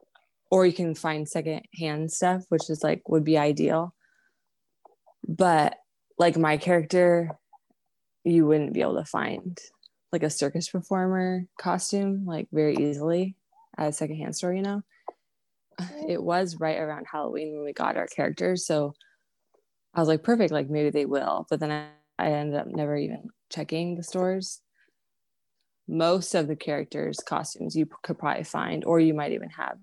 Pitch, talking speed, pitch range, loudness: 165 Hz, 165 wpm, 155-185 Hz, -27 LUFS